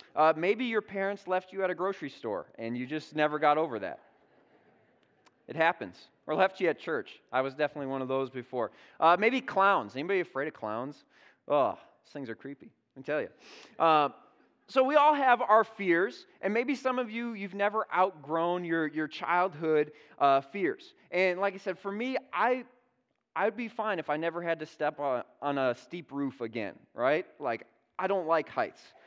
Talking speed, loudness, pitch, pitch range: 195 wpm, -30 LUFS, 180 Hz, 150-210 Hz